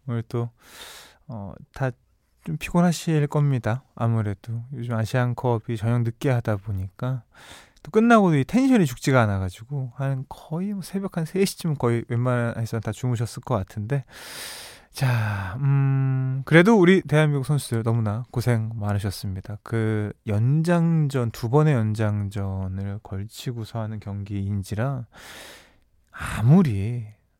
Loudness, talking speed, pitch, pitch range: -24 LUFS, 270 characters per minute, 120 Hz, 110-140 Hz